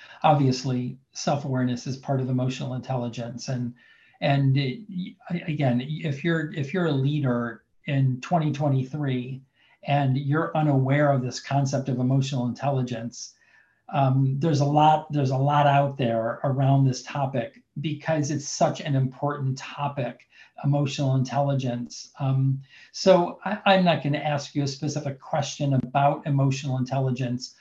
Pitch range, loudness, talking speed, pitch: 130-150 Hz, -25 LUFS, 135 wpm, 140 Hz